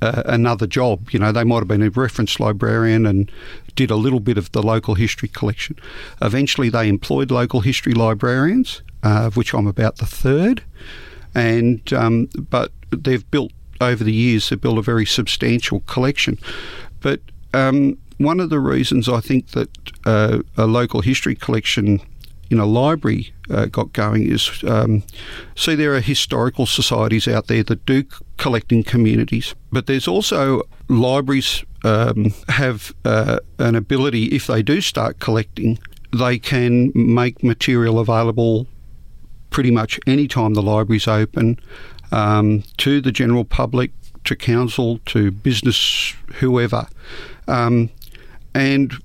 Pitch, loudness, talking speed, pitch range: 120 Hz, -18 LUFS, 150 wpm, 110-130 Hz